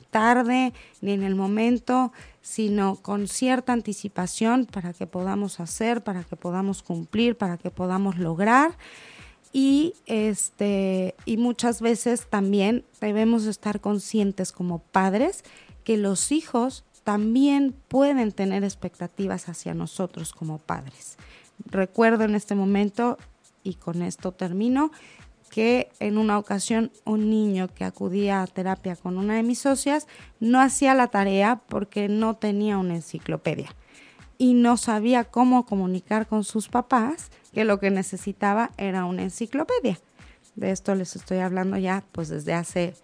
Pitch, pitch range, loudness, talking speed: 205 Hz, 190-235 Hz, -24 LUFS, 140 wpm